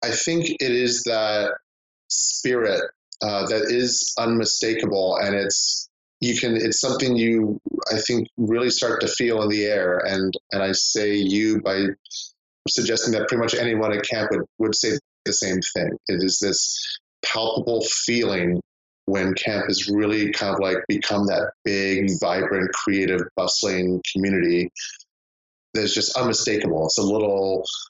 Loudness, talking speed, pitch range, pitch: -22 LUFS, 150 wpm, 95-115 Hz, 100 Hz